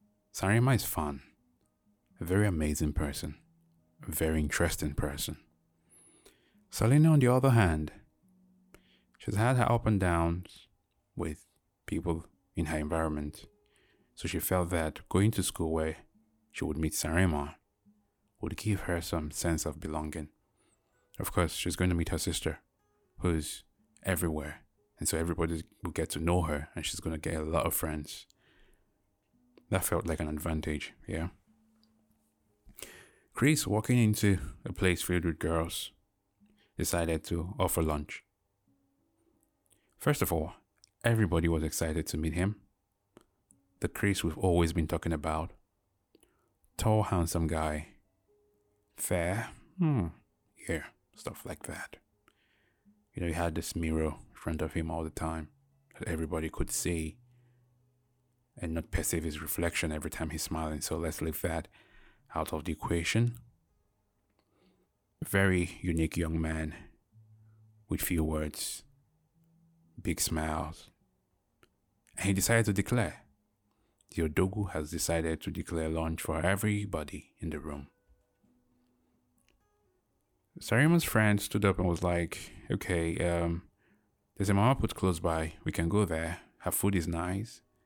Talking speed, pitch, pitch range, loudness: 135 wpm, 90 Hz, 80-105 Hz, -32 LUFS